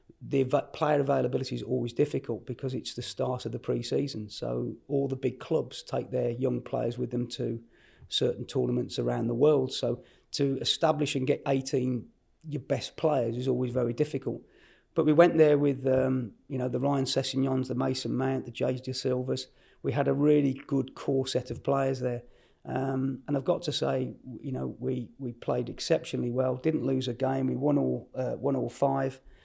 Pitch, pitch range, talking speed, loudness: 130 Hz, 125-140 Hz, 190 wpm, -29 LUFS